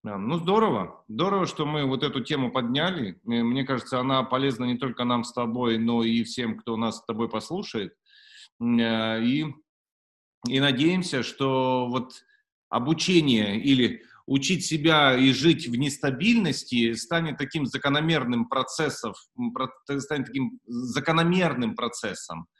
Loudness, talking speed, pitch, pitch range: -25 LUFS, 125 wpm, 135 Hz, 120-160 Hz